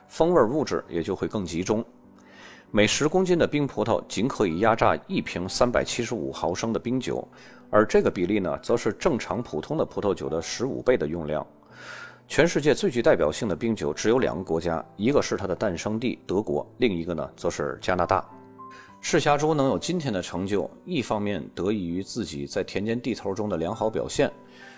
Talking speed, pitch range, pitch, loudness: 300 characters per minute, 85-125 Hz, 105 Hz, -26 LUFS